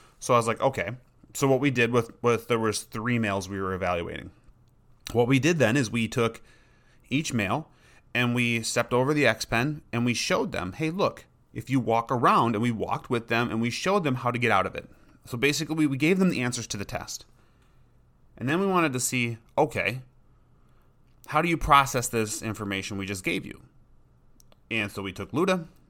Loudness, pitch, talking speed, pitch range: -26 LUFS, 120 Hz, 215 wpm, 115-135 Hz